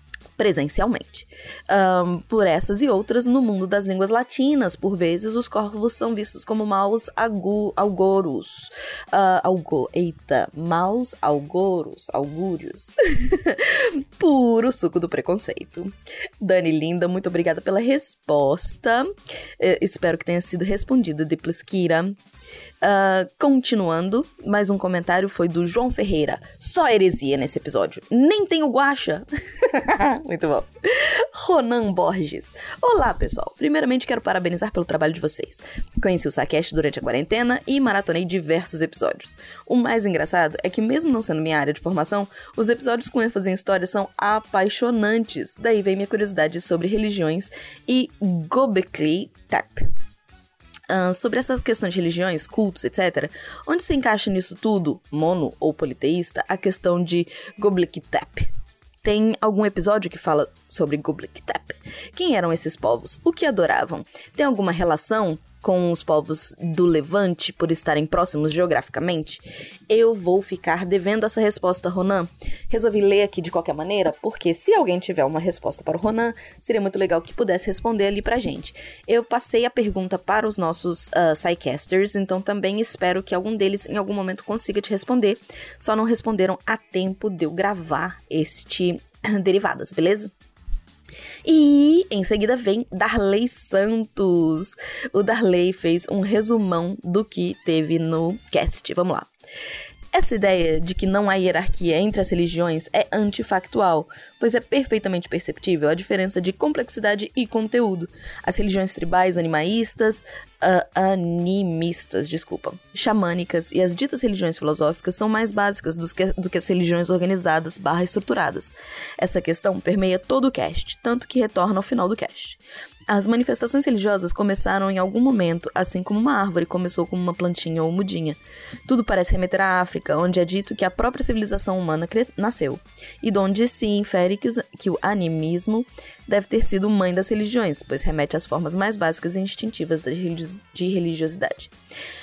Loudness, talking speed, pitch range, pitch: -21 LUFS, 150 wpm, 175-220 Hz, 190 Hz